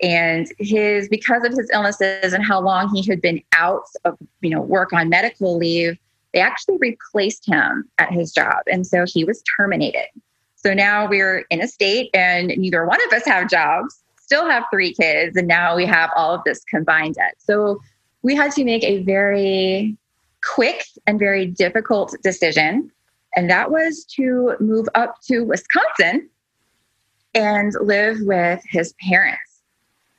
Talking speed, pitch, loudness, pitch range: 165 wpm, 195 Hz, -17 LUFS, 175-220 Hz